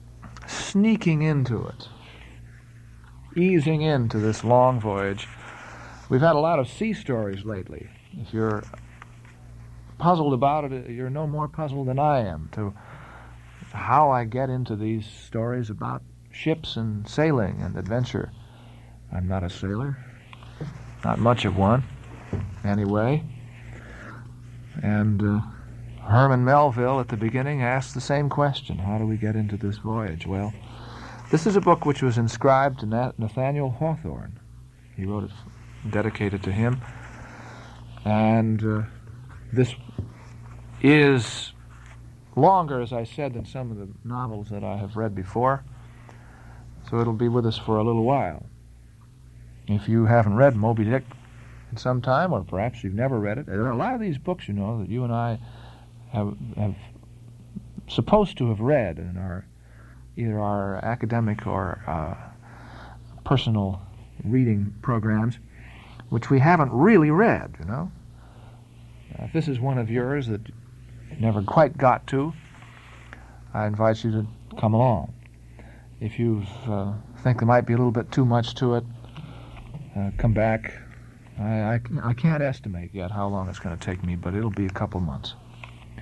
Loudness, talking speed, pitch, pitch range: -24 LUFS, 150 wpm, 115 Hz, 105-125 Hz